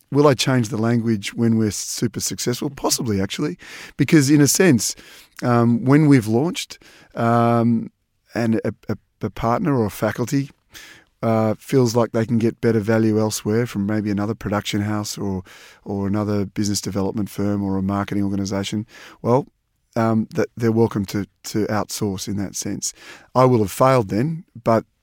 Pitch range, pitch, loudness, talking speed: 105-120 Hz, 110 Hz, -20 LUFS, 165 wpm